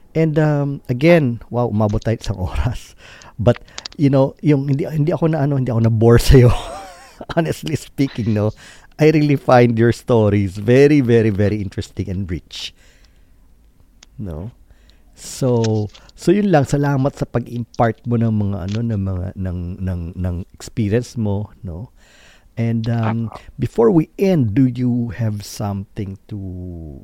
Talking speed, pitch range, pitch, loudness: 150 wpm, 100-135 Hz, 115 Hz, -17 LUFS